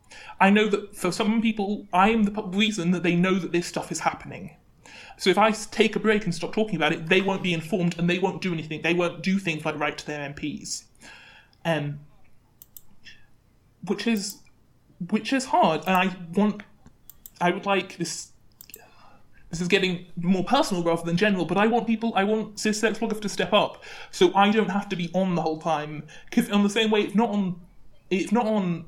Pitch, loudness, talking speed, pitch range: 185 Hz, -24 LUFS, 200 wpm, 165-210 Hz